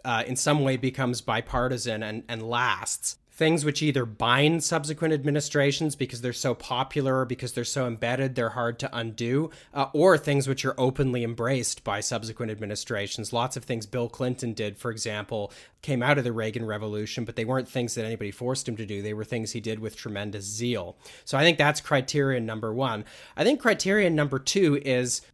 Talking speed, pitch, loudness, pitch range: 195 wpm, 125 Hz, -27 LUFS, 115-140 Hz